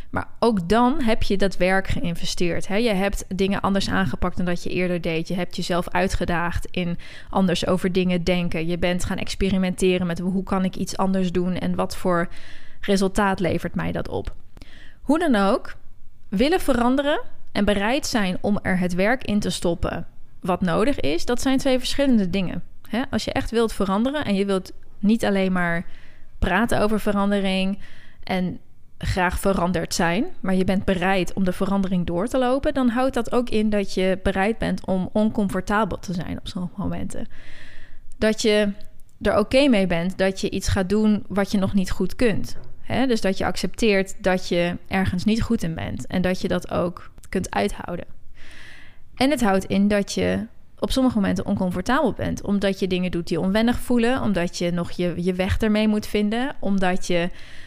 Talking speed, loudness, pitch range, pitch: 185 wpm, -23 LUFS, 180-215 Hz, 195 Hz